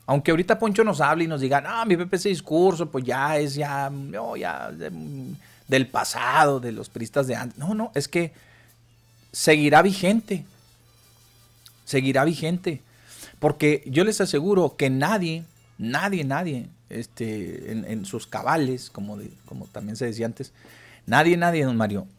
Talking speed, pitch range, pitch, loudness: 160 wpm, 120-165 Hz, 140 Hz, -23 LUFS